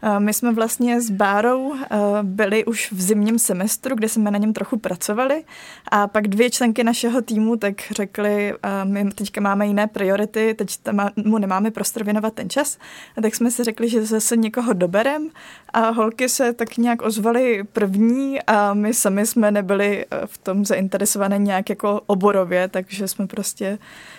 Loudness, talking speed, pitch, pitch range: -20 LUFS, 165 wpm, 215 Hz, 200-235 Hz